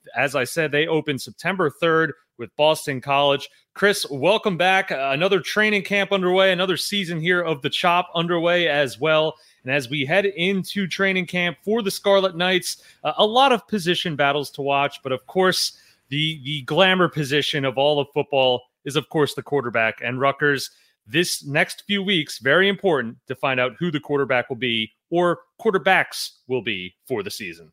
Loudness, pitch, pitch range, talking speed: -21 LUFS, 155 Hz, 140-185 Hz, 180 wpm